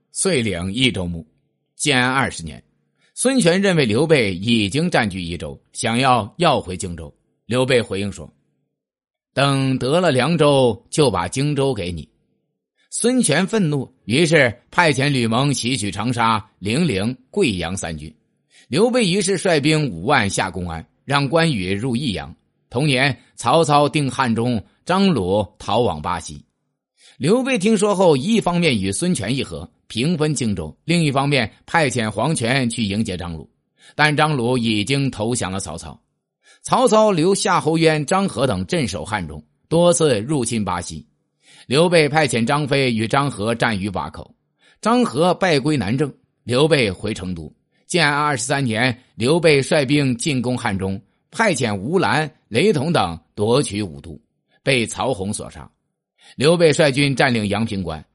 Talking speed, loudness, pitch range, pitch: 225 characters per minute, -19 LUFS, 100-155 Hz, 130 Hz